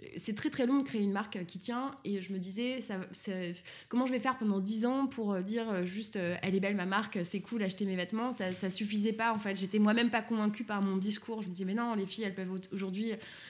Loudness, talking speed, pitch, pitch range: -34 LUFS, 260 wpm, 205 Hz, 190-230 Hz